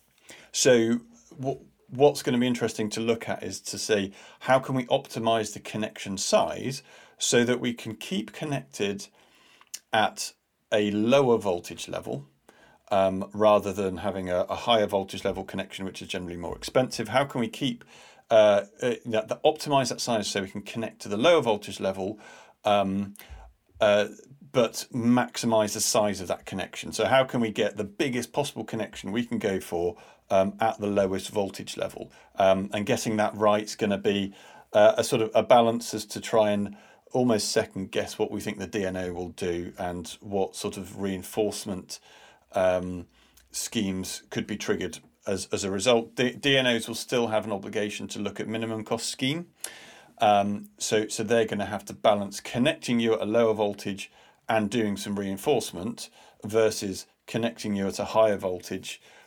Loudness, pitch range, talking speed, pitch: -27 LUFS, 100-115 Hz, 180 wpm, 105 Hz